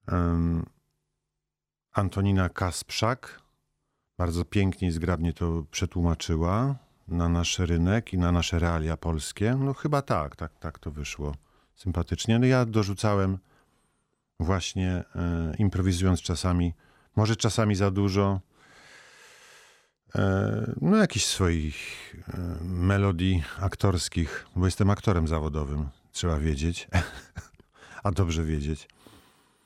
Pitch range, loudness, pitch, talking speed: 85-105 Hz, -27 LUFS, 90 Hz, 105 wpm